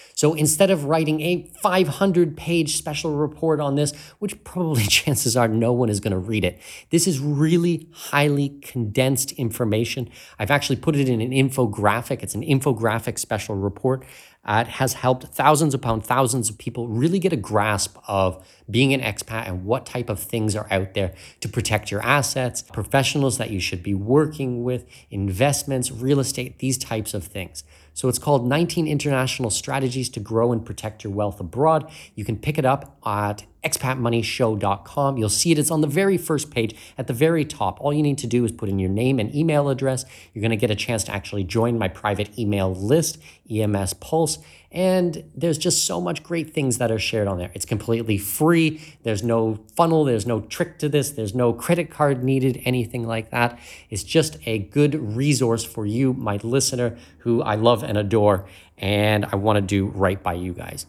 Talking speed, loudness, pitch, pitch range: 195 wpm, -22 LUFS, 120 Hz, 105-145 Hz